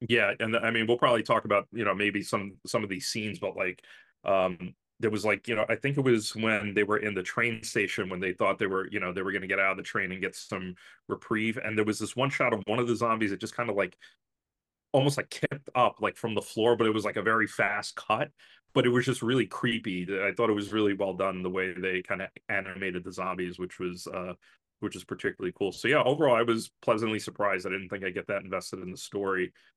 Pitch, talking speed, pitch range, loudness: 105 Hz, 270 wpm, 95-115 Hz, -29 LUFS